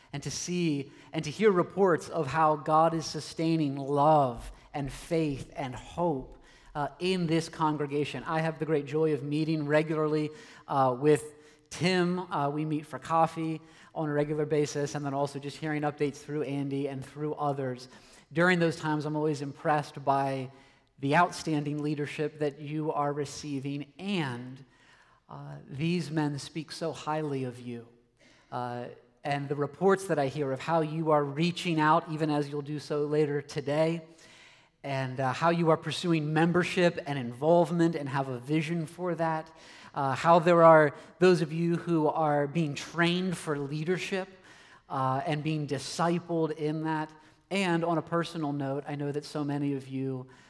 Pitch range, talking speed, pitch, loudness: 140-160 Hz, 170 wpm, 150 Hz, -29 LUFS